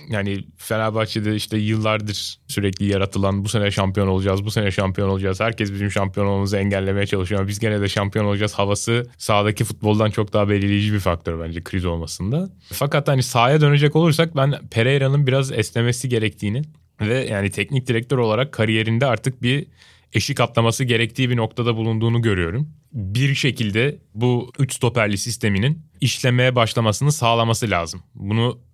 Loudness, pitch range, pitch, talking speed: -20 LUFS, 100-125 Hz, 110 Hz, 150 wpm